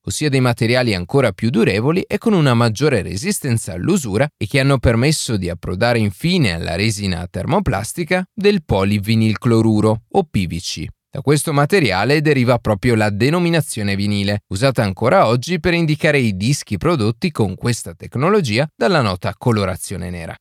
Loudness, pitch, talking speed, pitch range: -17 LUFS, 120 Hz, 145 wpm, 105-150 Hz